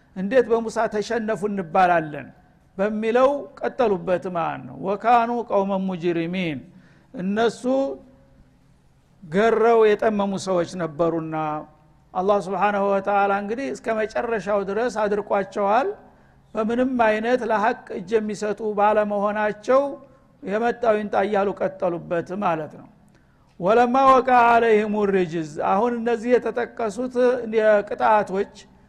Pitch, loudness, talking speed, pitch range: 210 Hz, -22 LUFS, 85 wpm, 190-230 Hz